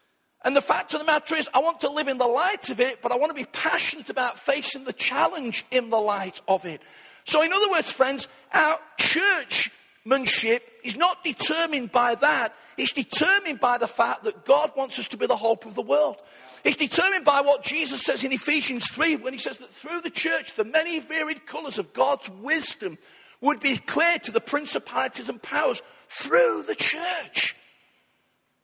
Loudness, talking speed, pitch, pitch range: -24 LUFS, 195 wpm, 280 Hz, 245-315 Hz